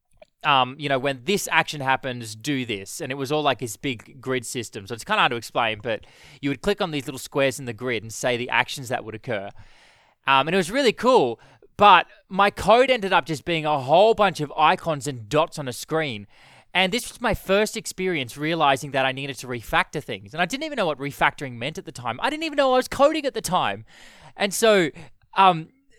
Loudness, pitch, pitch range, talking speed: -22 LUFS, 150 Hz, 130-190 Hz, 240 wpm